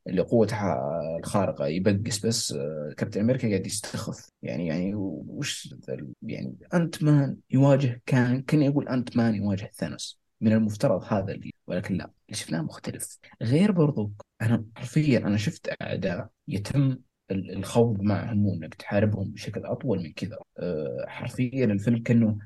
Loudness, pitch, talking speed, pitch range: -27 LUFS, 115 Hz, 140 wpm, 105-130 Hz